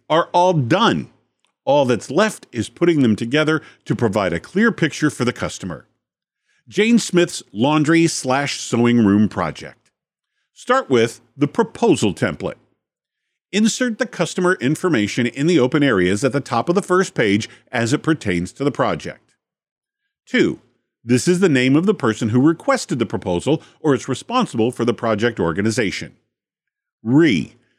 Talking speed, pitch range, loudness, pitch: 155 wpm, 115-180 Hz, -18 LUFS, 145 Hz